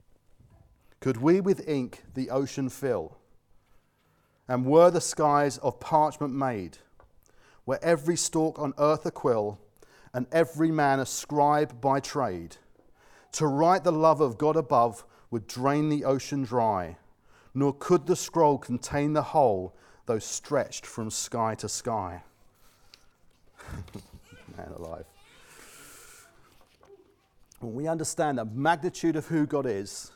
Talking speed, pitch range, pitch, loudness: 125 wpm, 115-160 Hz, 140 Hz, -27 LUFS